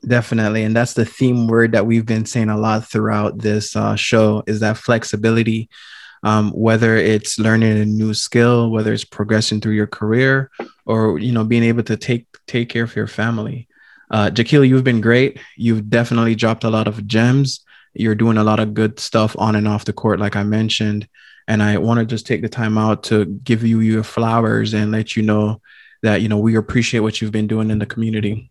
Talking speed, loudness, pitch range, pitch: 215 wpm, -17 LUFS, 110-115 Hz, 110 Hz